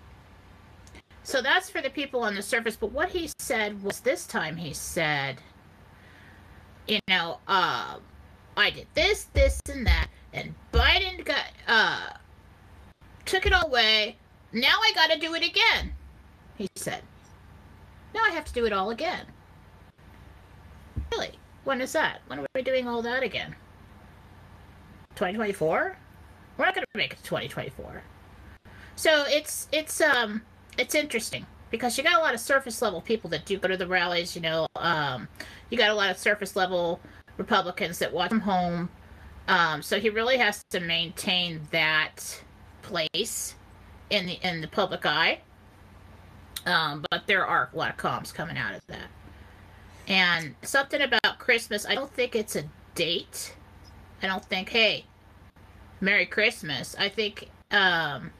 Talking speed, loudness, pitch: 155 wpm, -26 LUFS, 185 Hz